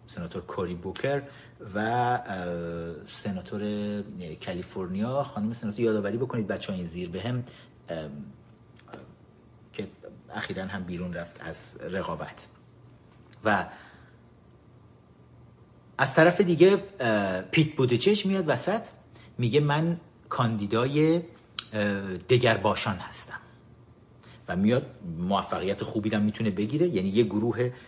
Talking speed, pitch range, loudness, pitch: 100 wpm, 100-130 Hz, -28 LUFS, 110 Hz